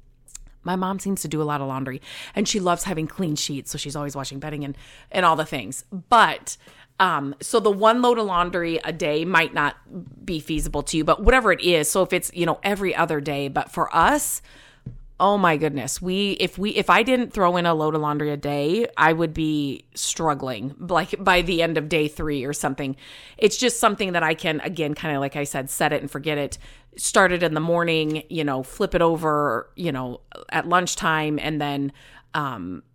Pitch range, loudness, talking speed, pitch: 145-180 Hz, -22 LUFS, 220 wpm, 155 Hz